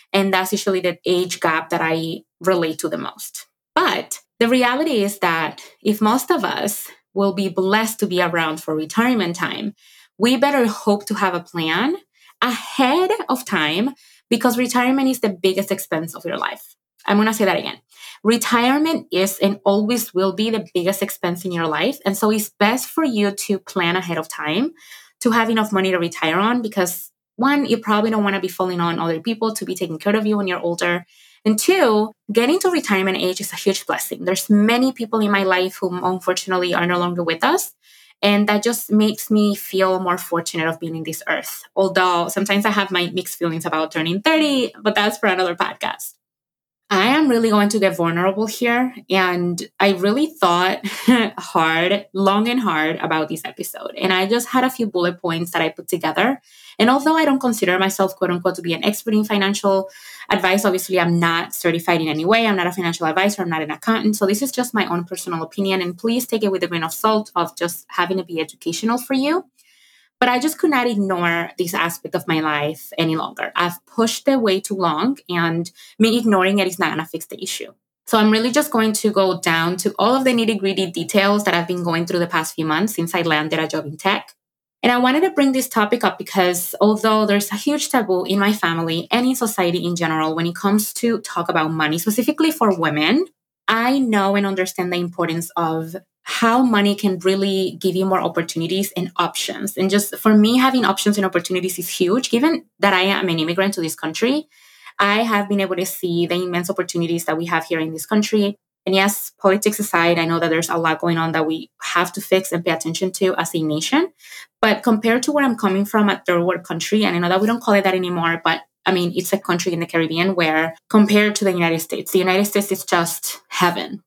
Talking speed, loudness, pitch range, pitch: 220 wpm, -19 LUFS, 175-220 Hz, 190 Hz